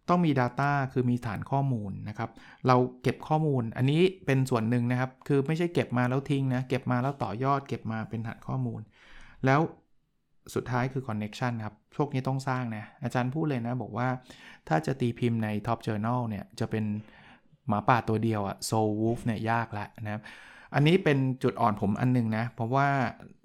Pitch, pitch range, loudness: 125 Hz, 110-135 Hz, -29 LUFS